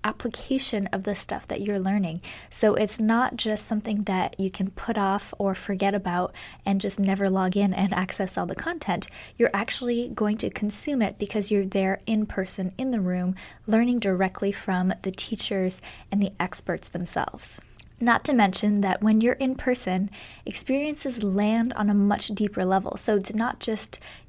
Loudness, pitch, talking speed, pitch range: -26 LUFS, 205 Hz, 180 wpm, 190-225 Hz